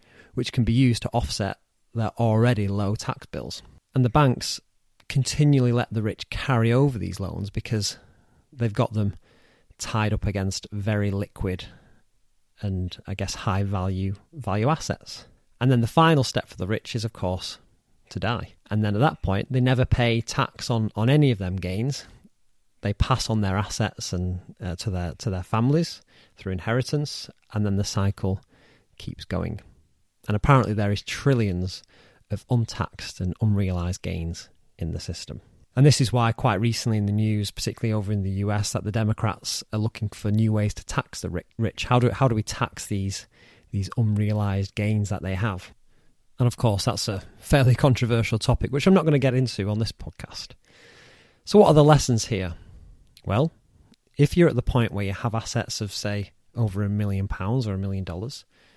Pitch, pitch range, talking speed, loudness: 110 Hz, 100-125 Hz, 185 wpm, -24 LUFS